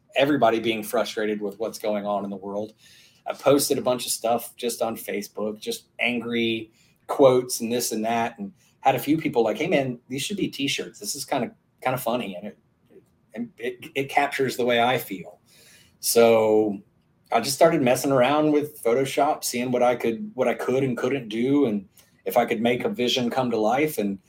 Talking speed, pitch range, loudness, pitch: 210 wpm, 115-135 Hz, -24 LUFS, 120 Hz